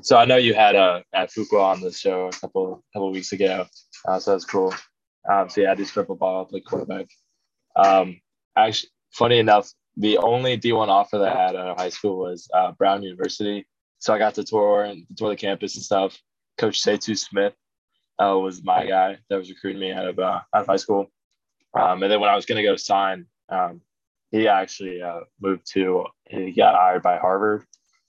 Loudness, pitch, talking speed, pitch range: -21 LUFS, 95 Hz, 215 wpm, 90-105 Hz